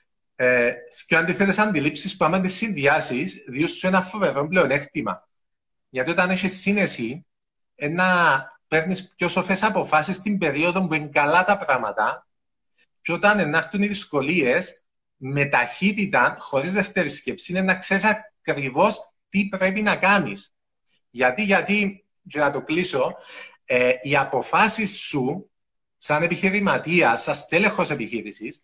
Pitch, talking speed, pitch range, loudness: 175 Hz, 130 wpm, 145-195 Hz, -21 LUFS